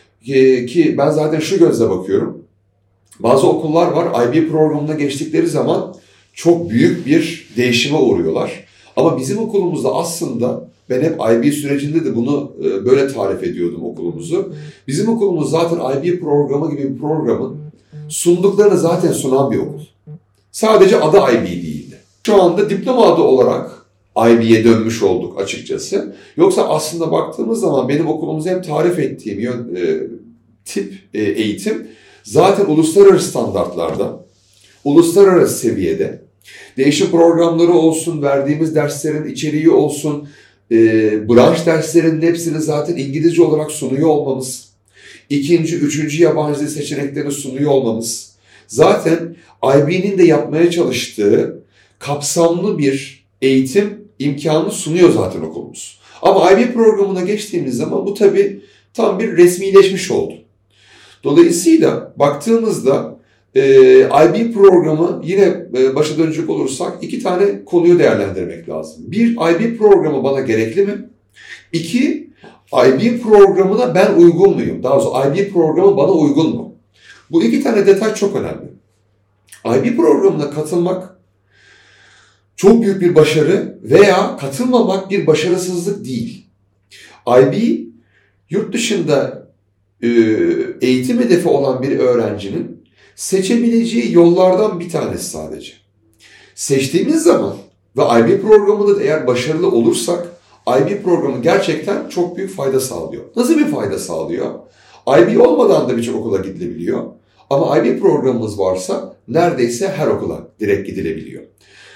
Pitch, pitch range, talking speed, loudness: 160 Hz, 130-195 Hz, 120 wpm, -14 LUFS